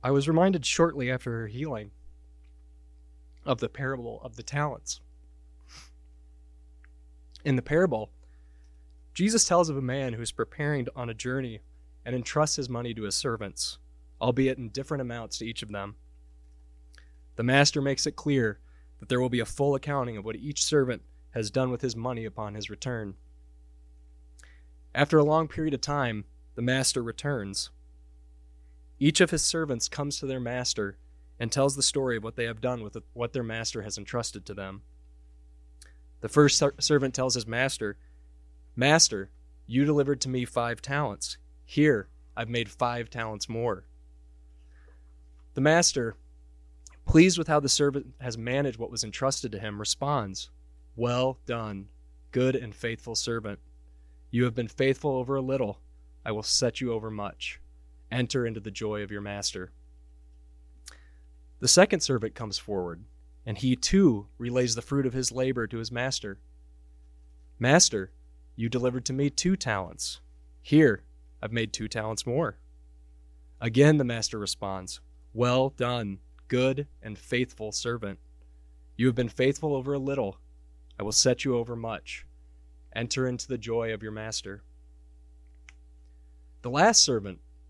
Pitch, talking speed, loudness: 110 Hz, 155 wpm, -27 LUFS